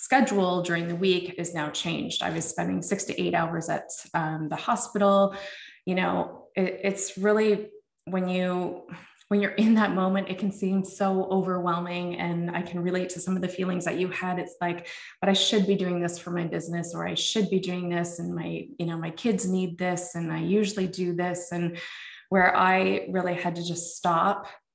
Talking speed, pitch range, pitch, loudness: 205 wpm, 175-195 Hz, 180 Hz, -27 LUFS